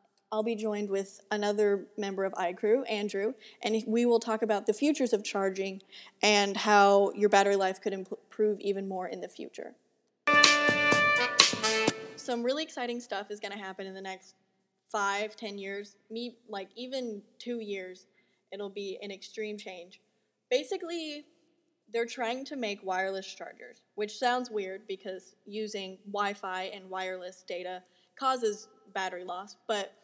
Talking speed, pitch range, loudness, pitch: 150 wpm, 195-230 Hz, -30 LUFS, 205 Hz